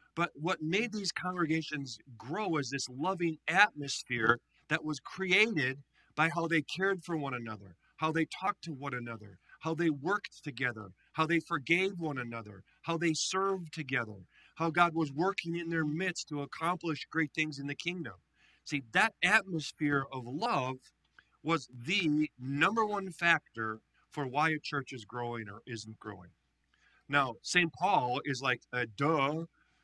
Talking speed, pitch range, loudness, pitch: 160 wpm, 130-170 Hz, -33 LUFS, 155 Hz